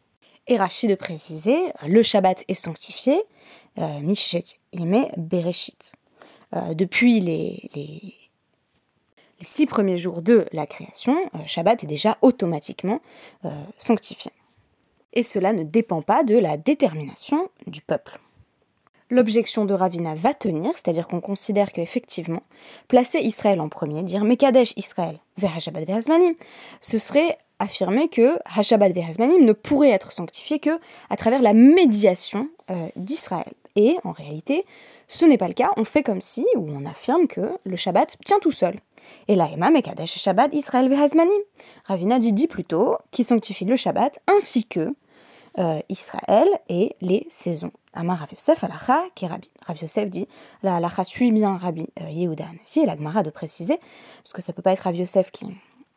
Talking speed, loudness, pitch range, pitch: 160 wpm, -21 LUFS, 180-255 Hz, 205 Hz